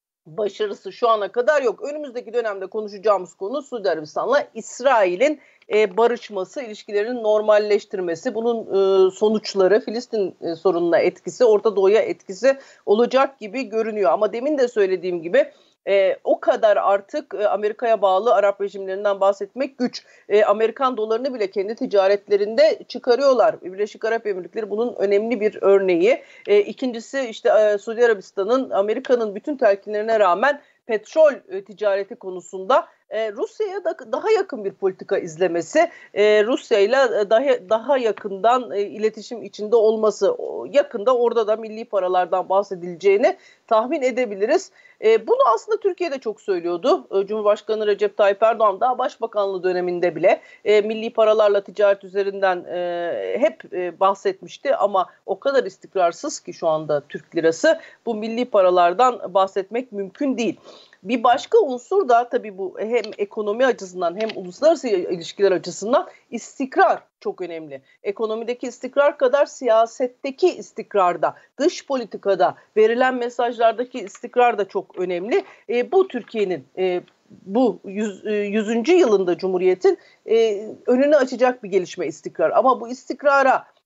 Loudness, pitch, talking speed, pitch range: -20 LUFS, 220 Hz, 130 wpm, 200-270 Hz